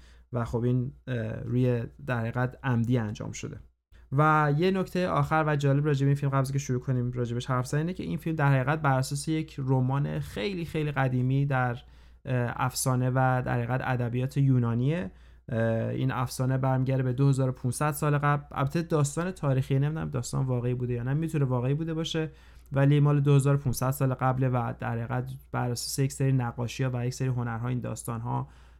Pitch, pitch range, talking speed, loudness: 130 Hz, 125-140 Hz, 175 wpm, -28 LUFS